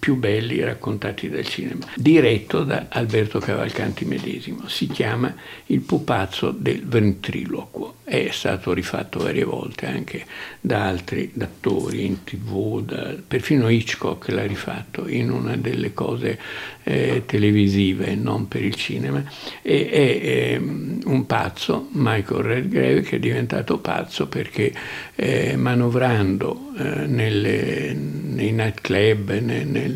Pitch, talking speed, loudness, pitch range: 105 Hz, 125 wpm, -22 LUFS, 100-115 Hz